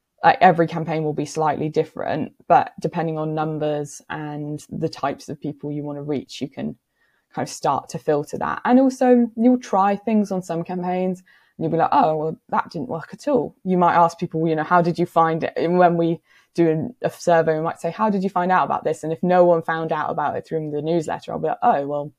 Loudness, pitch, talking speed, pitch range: -21 LUFS, 165 Hz, 245 wpm, 155-180 Hz